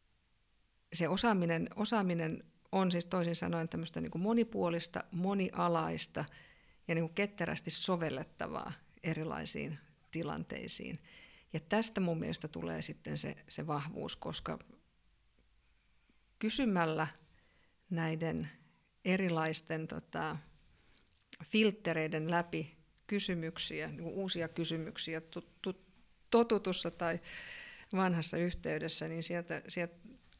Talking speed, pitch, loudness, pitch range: 90 wpm, 170 Hz, -36 LUFS, 160-185 Hz